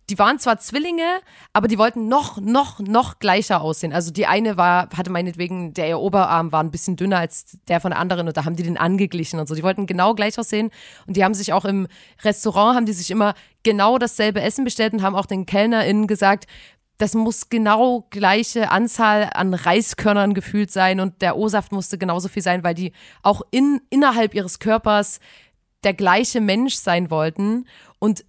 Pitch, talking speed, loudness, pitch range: 200 Hz, 195 wpm, -19 LUFS, 180-220 Hz